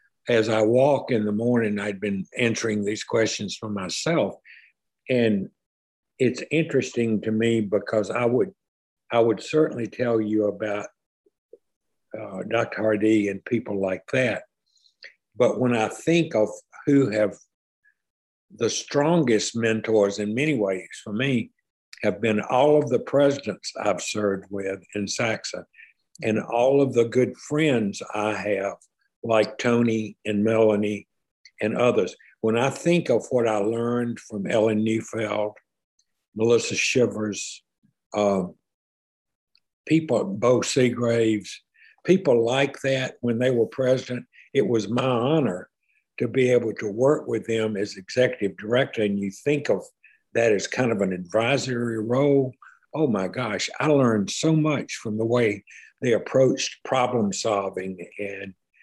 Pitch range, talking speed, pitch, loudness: 105-130 Hz, 140 wpm, 115 Hz, -24 LUFS